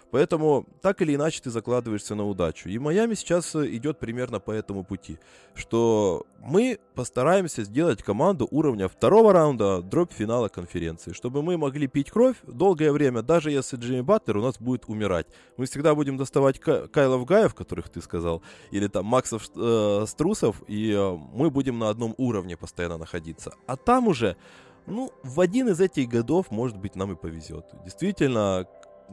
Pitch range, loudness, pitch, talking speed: 100-155 Hz, -25 LUFS, 125 Hz, 165 wpm